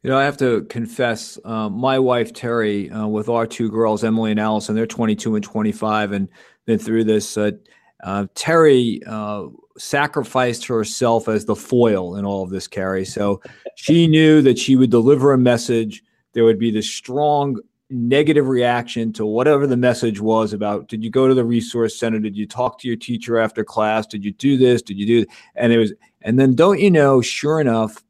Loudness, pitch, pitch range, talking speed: -18 LUFS, 115 Hz, 110-130 Hz, 205 wpm